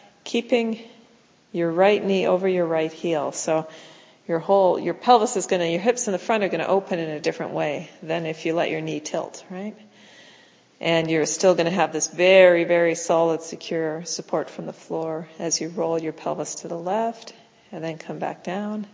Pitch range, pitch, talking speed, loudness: 160-195 Hz, 170 Hz, 205 wpm, -23 LUFS